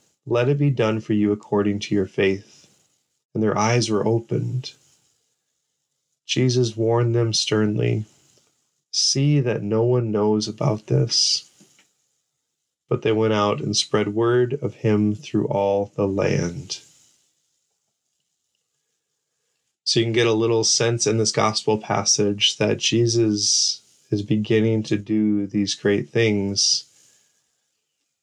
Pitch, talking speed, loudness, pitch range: 110 Hz, 125 wpm, -21 LUFS, 105-120 Hz